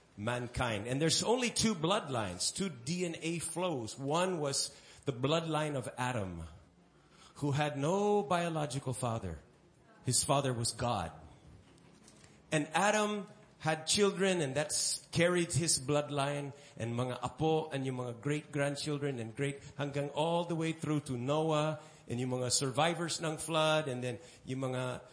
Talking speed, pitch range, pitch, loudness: 140 wpm, 125-160 Hz, 145 Hz, -34 LUFS